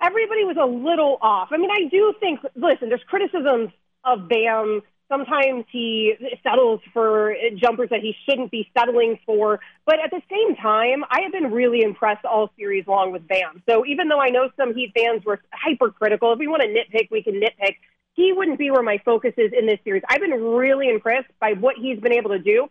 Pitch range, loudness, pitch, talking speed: 220-295 Hz, -20 LUFS, 245 Hz, 210 wpm